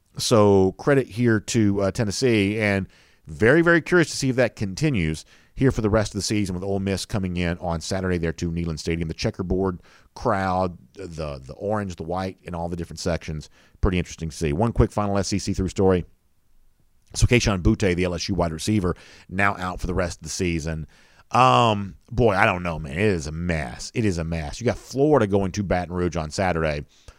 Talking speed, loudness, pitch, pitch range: 205 wpm, -23 LUFS, 95 Hz, 85-105 Hz